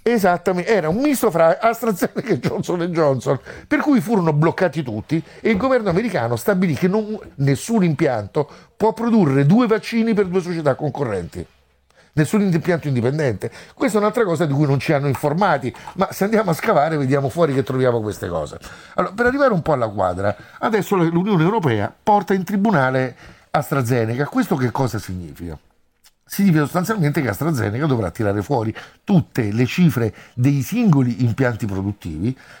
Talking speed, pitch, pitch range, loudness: 165 wpm, 160 Hz, 125-200 Hz, -19 LUFS